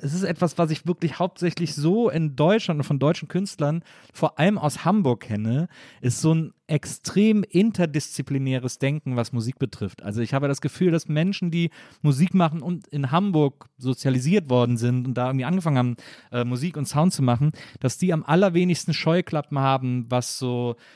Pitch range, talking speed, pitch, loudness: 130-175 Hz, 180 wpm, 150 Hz, -23 LUFS